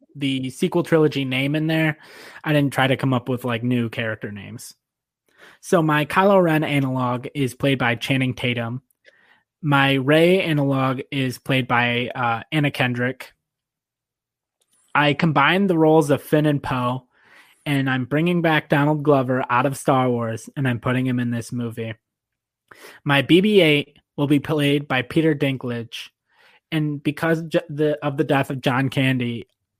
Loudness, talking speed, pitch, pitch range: -20 LUFS, 160 wpm, 135 Hz, 125-150 Hz